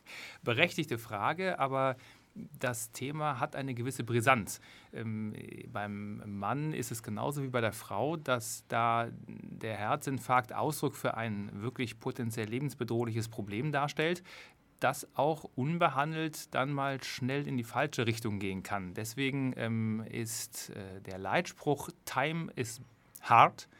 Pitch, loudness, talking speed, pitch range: 125 Hz, -34 LUFS, 130 wpm, 115-140 Hz